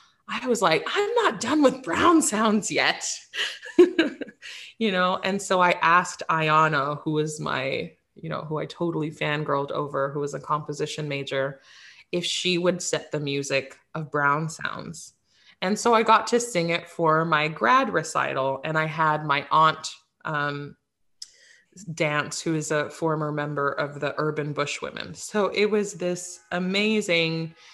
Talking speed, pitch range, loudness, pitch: 160 wpm, 150-205 Hz, -24 LUFS, 160 Hz